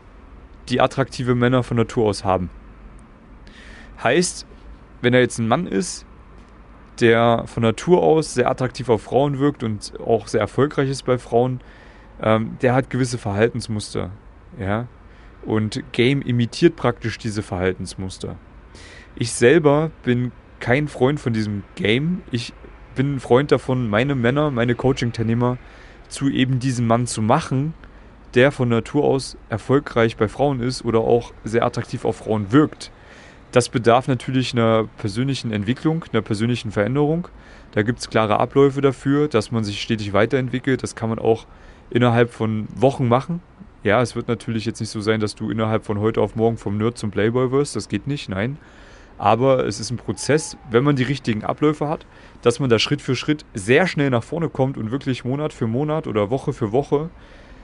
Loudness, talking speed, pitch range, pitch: -20 LUFS, 170 wpm, 110-130 Hz, 120 Hz